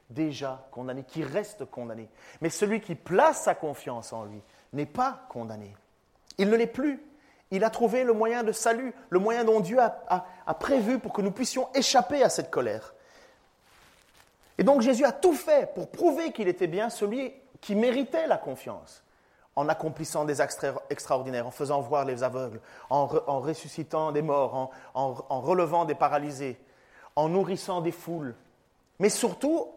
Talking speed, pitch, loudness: 180 wpm, 180 Hz, -28 LUFS